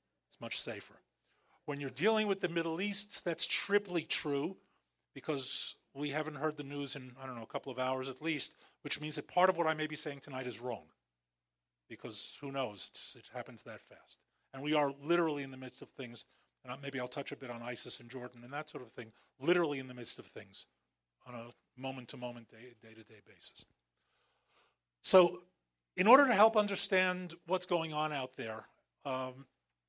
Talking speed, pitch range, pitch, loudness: 205 wpm, 125-160 Hz, 140 Hz, -35 LUFS